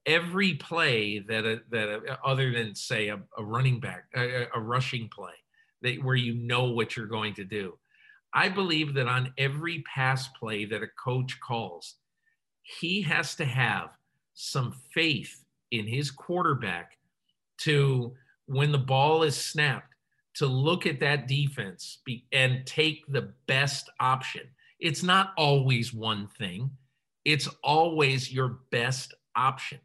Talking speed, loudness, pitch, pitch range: 140 wpm, -28 LUFS, 130 Hz, 120-150 Hz